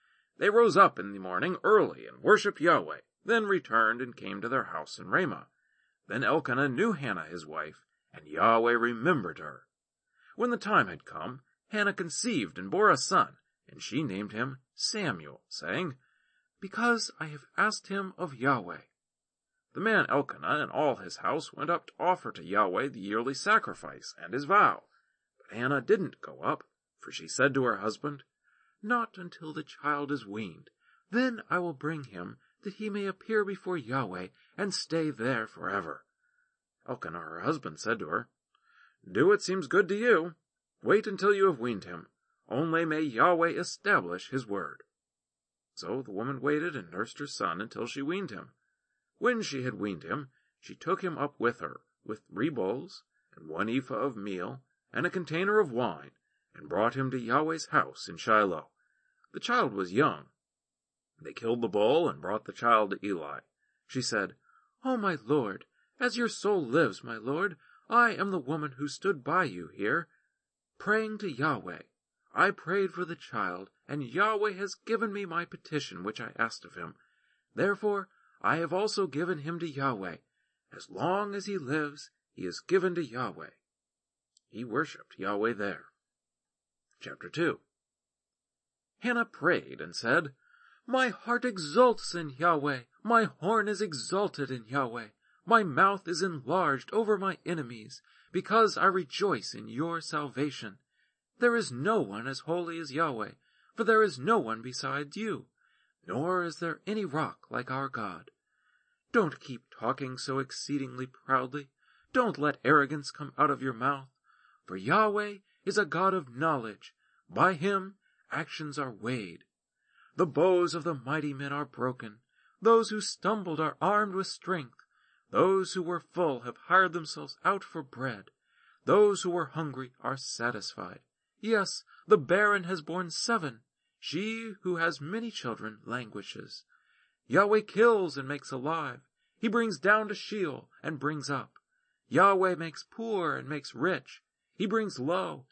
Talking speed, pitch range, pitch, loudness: 160 wpm, 135-205 Hz, 170 Hz, -30 LUFS